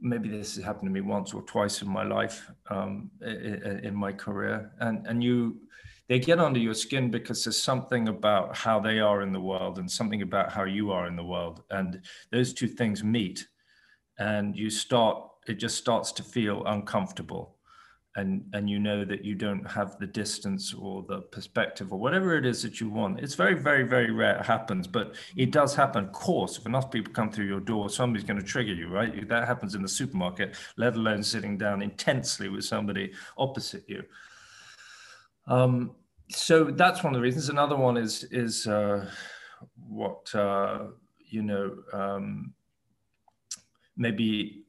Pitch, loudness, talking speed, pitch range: 110 Hz, -29 LUFS, 180 wpm, 100-125 Hz